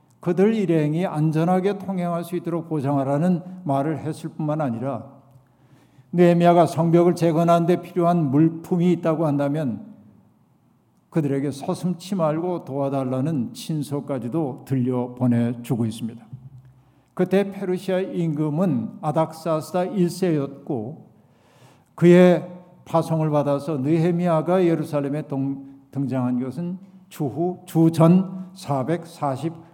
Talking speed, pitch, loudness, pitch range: 260 characters per minute, 160 Hz, -22 LUFS, 140-175 Hz